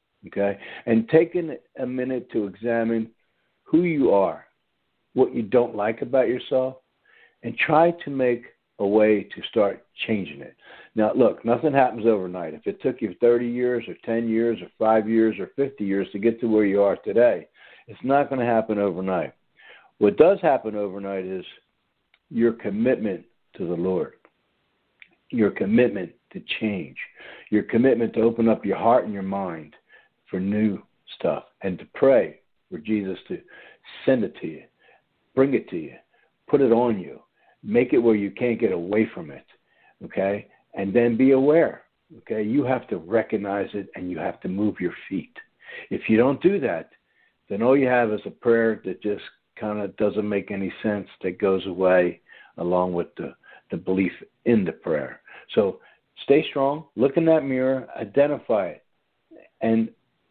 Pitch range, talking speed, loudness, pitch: 100-120 Hz, 170 wpm, -23 LUFS, 110 Hz